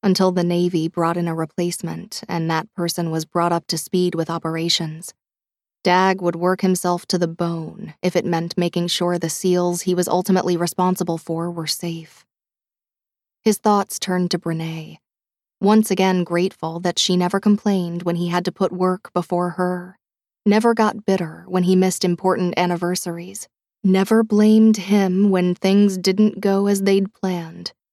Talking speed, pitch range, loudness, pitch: 165 wpm, 170-190 Hz, -20 LUFS, 180 Hz